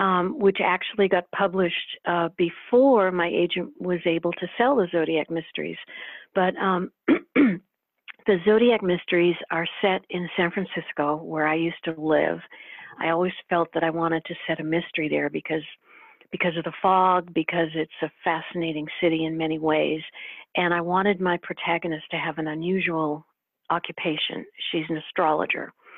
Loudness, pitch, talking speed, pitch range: -24 LUFS, 170 Hz, 155 wpm, 165-185 Hz